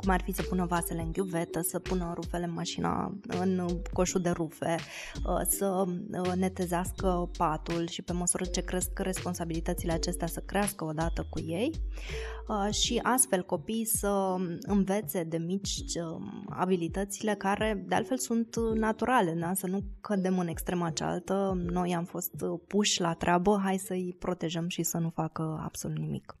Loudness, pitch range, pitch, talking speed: -31 LUFS, 170-195 Hz, 180 Hz, 150 wpm